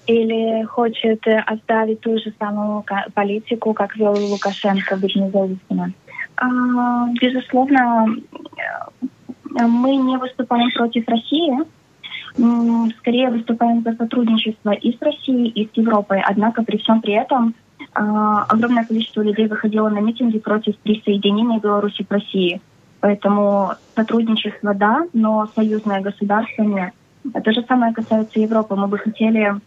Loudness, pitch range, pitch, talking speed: -18 LUFS, 210-235 Hz, 220 Hz, 120 wpm